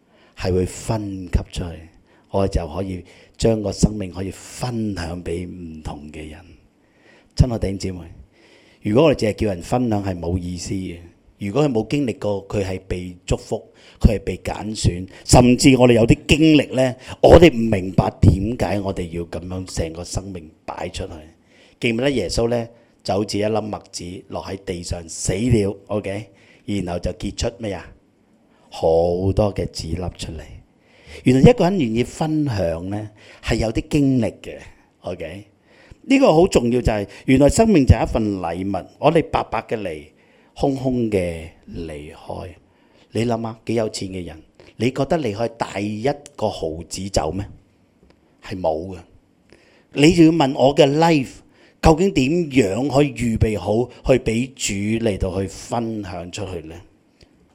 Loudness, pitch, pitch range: -20 LUFS, 100 Hz, 90-120 Hz